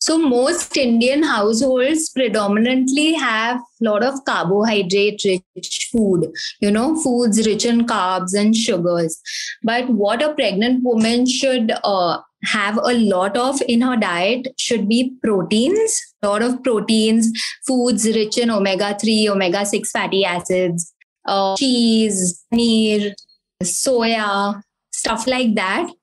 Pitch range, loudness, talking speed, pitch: 205-255 Hz, -17 LUFS, 130 wpm, 225 Hz